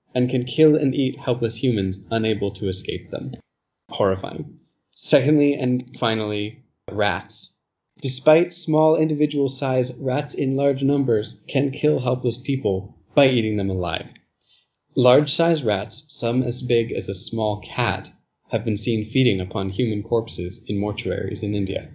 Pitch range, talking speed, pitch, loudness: 105-140 Hz, 145 wpm, 125 Hz, -22 LUFS